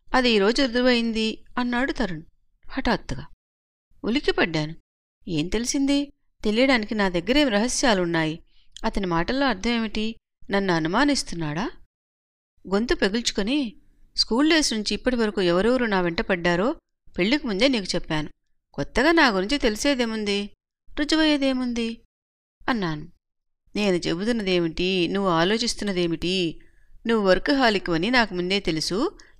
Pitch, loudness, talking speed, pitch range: 215 Hz, -23 LUFS, 95 wpm, 175-255 Hz